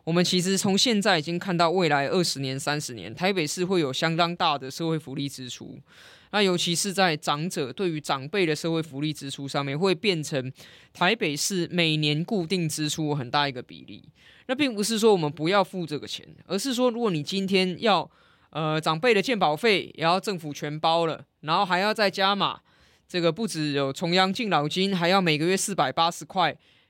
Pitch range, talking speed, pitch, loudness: 150-195 Hz, 300 characters per minute, 170 Hz, -25 LUFS